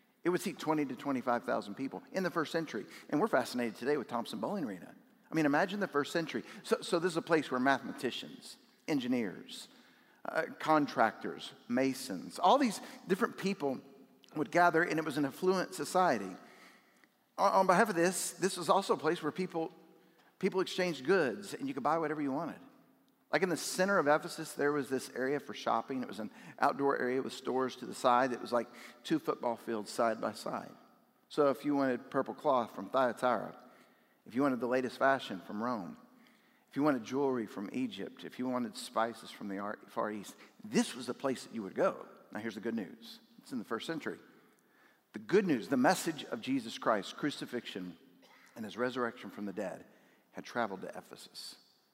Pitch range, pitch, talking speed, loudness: 130-185 Hz, 150 Hz, 195 wpm, -34 LUFS